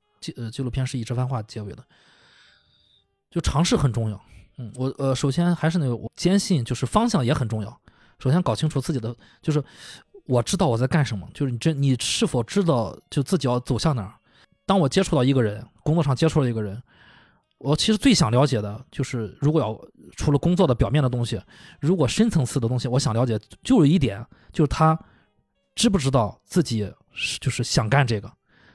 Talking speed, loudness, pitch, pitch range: 305 characters per minute, -23 LUFS, 130 Hz, 115-160 Hz